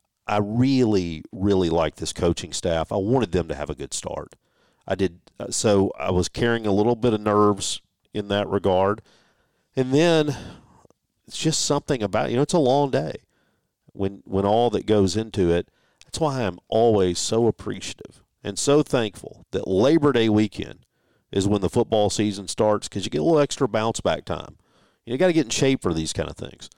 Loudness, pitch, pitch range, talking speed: -23 LUFS, 105 Hz, 95-125 Hz, 200 wpm